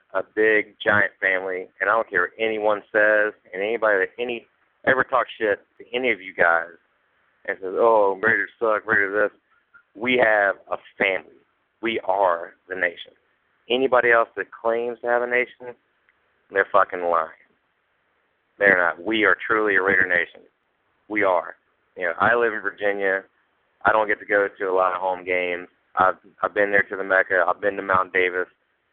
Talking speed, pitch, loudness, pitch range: 185 wpm, 105 Hz, -21 LUFS, 95-120 Hz